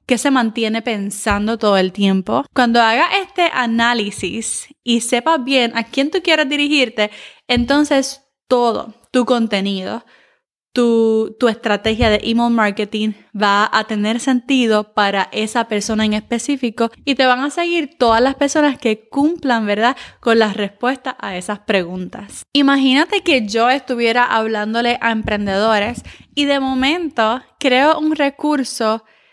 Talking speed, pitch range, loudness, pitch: 140 wpm, 215-275 Hz, -16 LUFS, 235 Hz